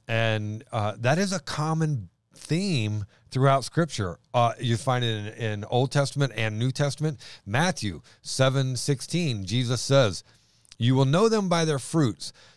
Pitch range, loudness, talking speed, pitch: 110-145 Hz, -26 LUFS, 150 wpm, 130 Hz